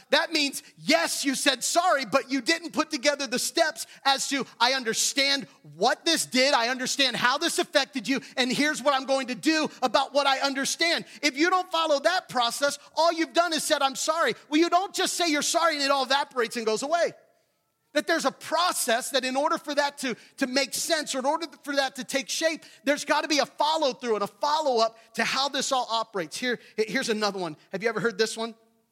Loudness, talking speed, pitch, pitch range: -25 LUFS, 225 wpm, 275 Hz, 245-310 Hz